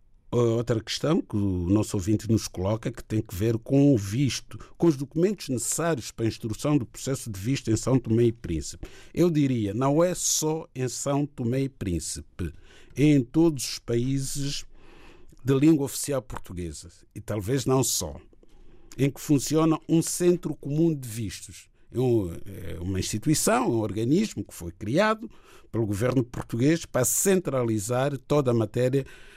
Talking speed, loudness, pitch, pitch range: 155 wpm, -26 LUFS, 120 Hz, 110-140 Hz